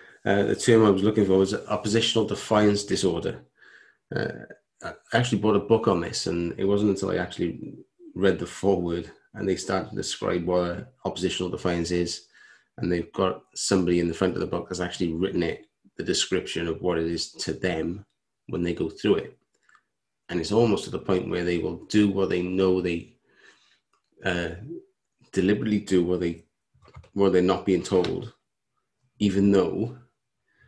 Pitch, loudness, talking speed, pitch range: 95 Hz, -25 LUFS, 170 wpm, 85-105 Hz